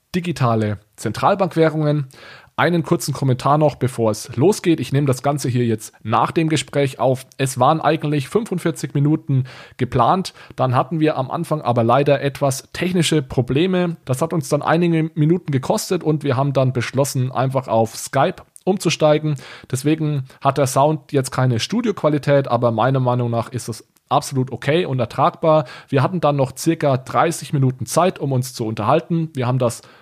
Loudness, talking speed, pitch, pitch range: -19 LUFS, 165 wpm, 140 Hz, 130-160 Hz